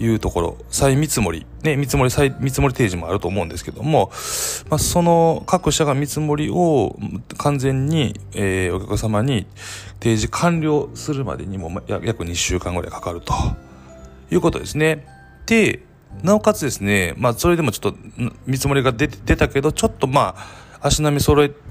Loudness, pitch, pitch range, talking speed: -19 LUFS, 130 Hz, 100-150 Hz, 335 characters per minute